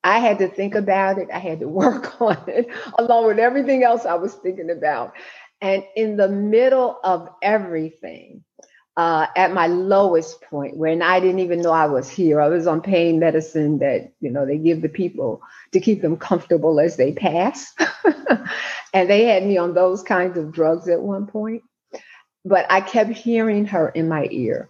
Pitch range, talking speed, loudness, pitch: 165-205 Hz, 190 wpm, -19 LUFS, 185 Hz